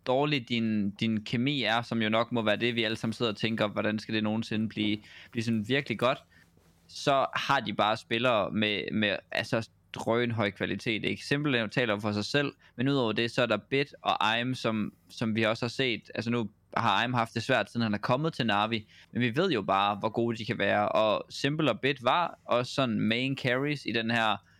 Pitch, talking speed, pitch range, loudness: 115 Hz, 225 wpm, 105-120 Hz, -29 LUFS